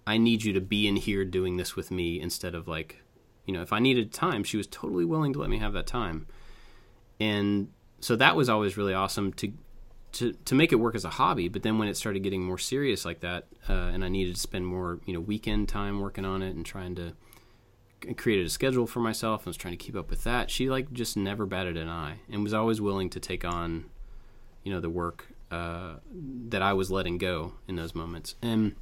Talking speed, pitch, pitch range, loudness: 235 wpm, 100 Hz, 90-110 Hz, -30 LUFS